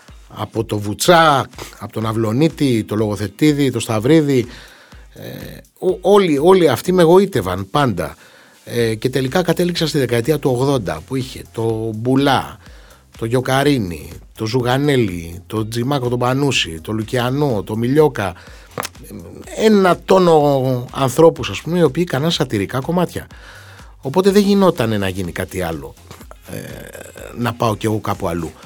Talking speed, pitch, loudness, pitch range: 140 wpm, 125 Hz, -16 LUFS, 105-150 Hz